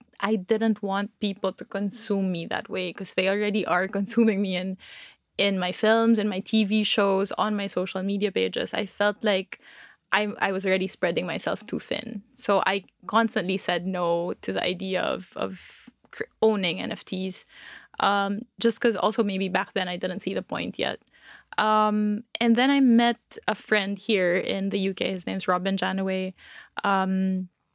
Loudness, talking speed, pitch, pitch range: -25 LUFS, 175 wpm, 200 Hz, 190-215 Hz